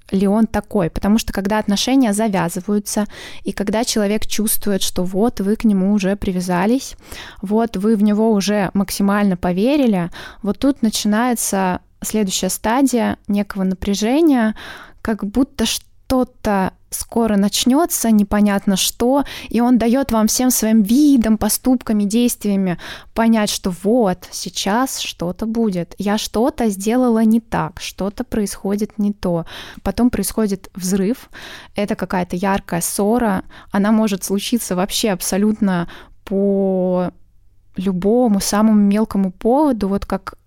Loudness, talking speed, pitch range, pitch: -18 LUFS, 125 wpm, 195-225 Hz, 210 Hz